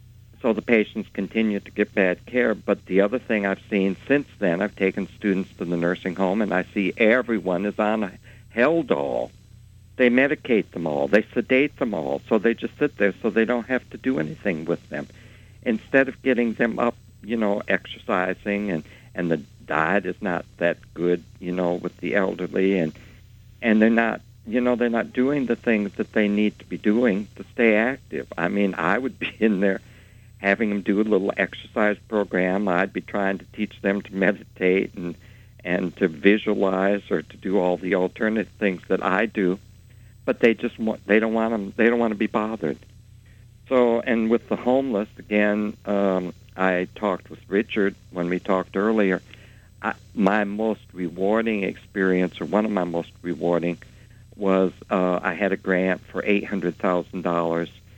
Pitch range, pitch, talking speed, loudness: 95-115 Hz, 105 Hz, 190 wpm, -23 LUFS